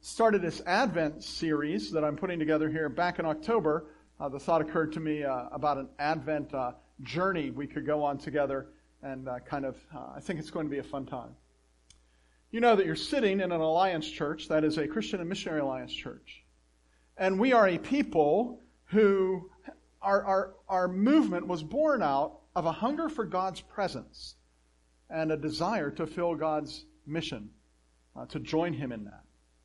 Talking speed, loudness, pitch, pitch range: 185 wpm, -30 LUFS, 155 Hz, 135-185 Hz